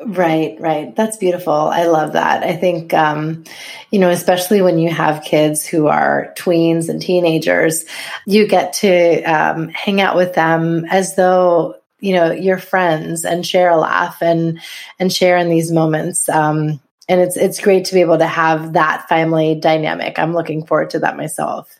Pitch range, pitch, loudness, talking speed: 160-180 Hz, 170 Hz, -15 LUFS, 180 wpm